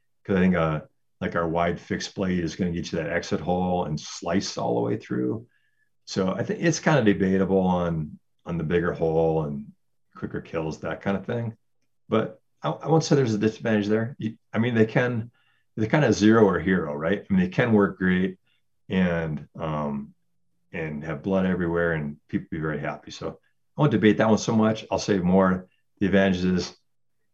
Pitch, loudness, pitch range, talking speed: 95 Hz, -25 LUFS, 85-110 Hz, 200 wpm